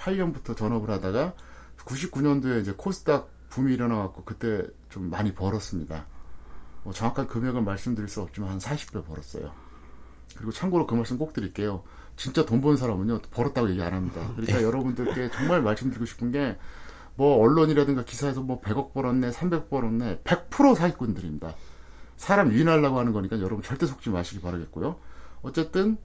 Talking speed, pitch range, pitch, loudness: 375 characters per minute, 90-135 Hz, 115 Hz, -27 LUFS